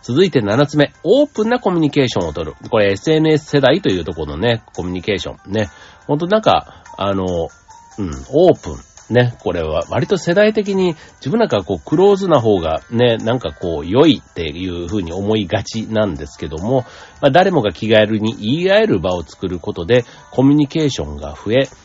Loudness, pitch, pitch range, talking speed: -16 LUFS, 115 Hz, 95-150 Hz, 400 characters per minute